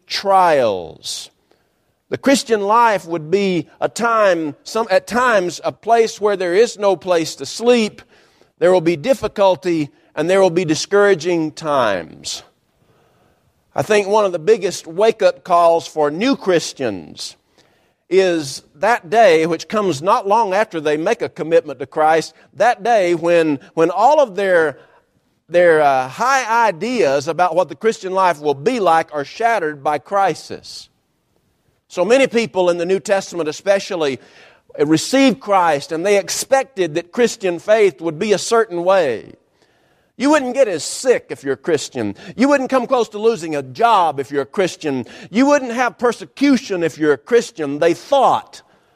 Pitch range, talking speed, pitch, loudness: 165-230 Hz, 160 wpm, 190 Hz, -16 LUFS